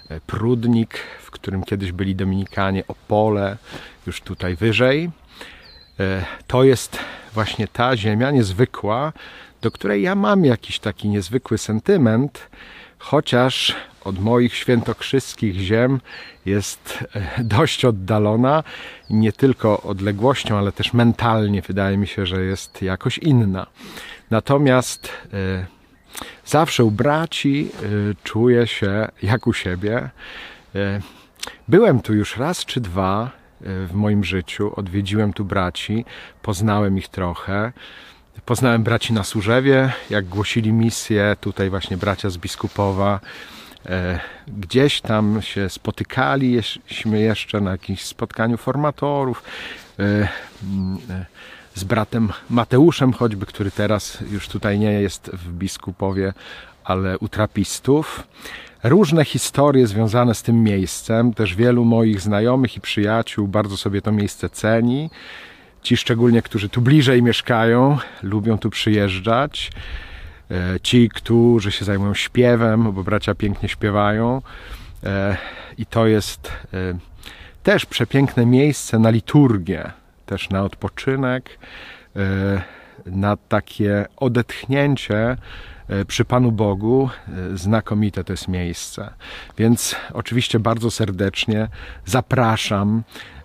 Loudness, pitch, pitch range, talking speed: -19 LUFS, 105 Hz, 100-120 Hz, 110 wpm